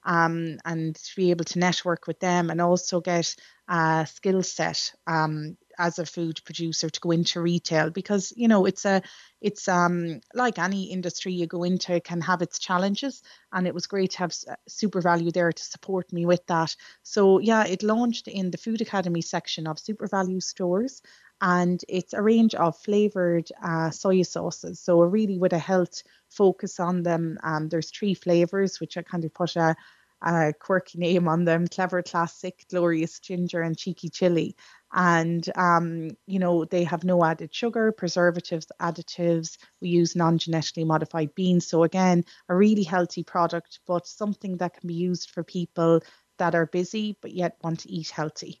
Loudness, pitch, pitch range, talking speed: -25 LUFS, 175 Hz, 165-185 Hz, 185 wpm